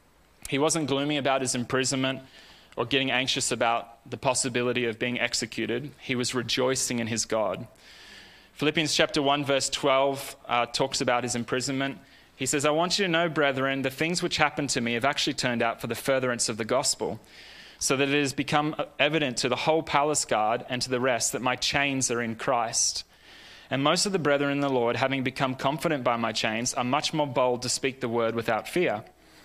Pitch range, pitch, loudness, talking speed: 125-145 Hz, 135 Hz, -26 LUFS, 205 wpm